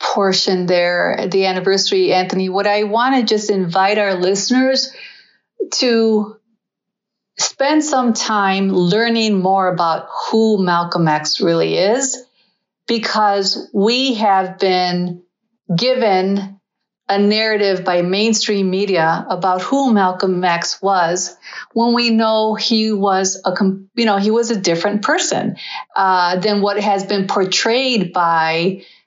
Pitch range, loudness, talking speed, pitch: 185-225 Hz, -16 LUFS, 125 wpm, 200 Hz